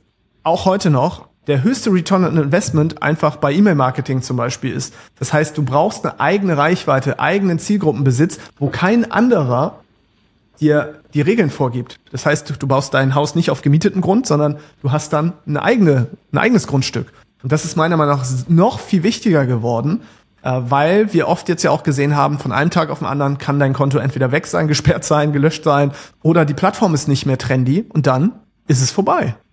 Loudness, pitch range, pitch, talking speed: -16 LUFS, 140-175 Hz, 150 Hz, 195 wpm